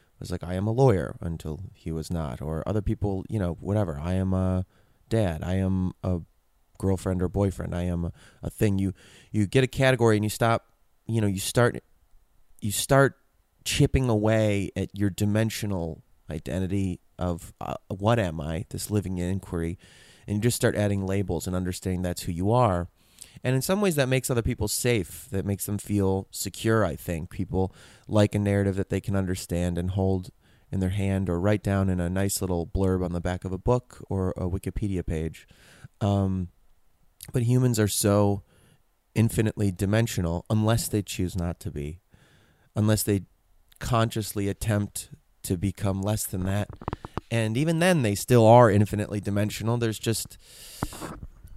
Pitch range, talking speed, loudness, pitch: 90-110 Hz, 175 wpm, -26 LUFS, 100 Hz